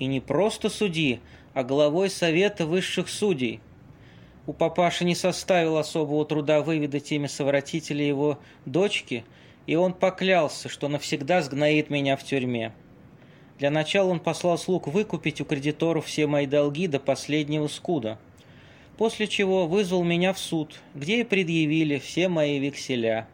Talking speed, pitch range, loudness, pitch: 140 wpm, 140-180 Hz, -25 LUFS, 155 Hz